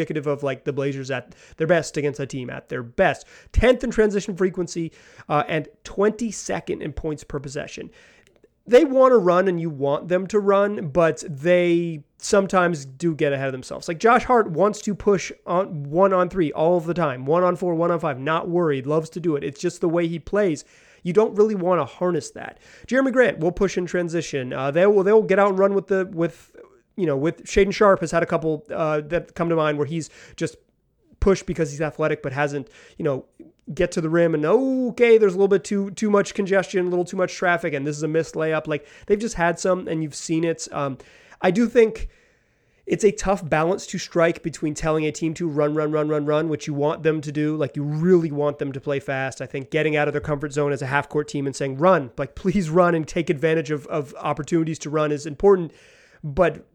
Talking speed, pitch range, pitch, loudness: 225 wpm, 150-190 Hz, 165 Hz, -22 LUFS